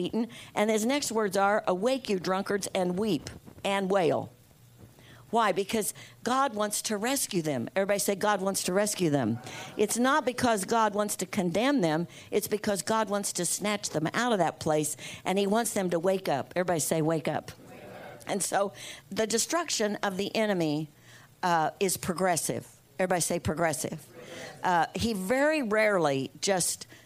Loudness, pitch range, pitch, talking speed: -28 LUFS, 165-215 Hz, 195 Hz, 165 wpm